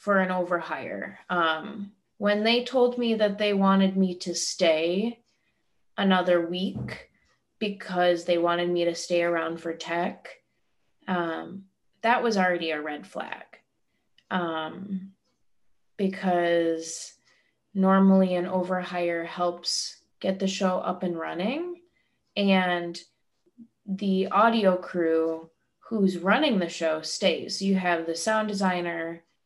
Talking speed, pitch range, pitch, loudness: 120 wpm, 170-200 Hz, 185 Hz, -26 LUFS